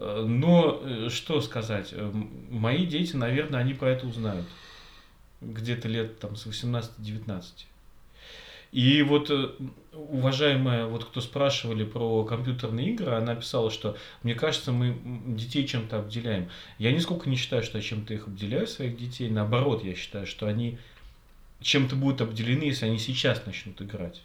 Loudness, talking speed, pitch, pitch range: -28 LUFS, 140 wpm, 115 Hz, 110-130 Hz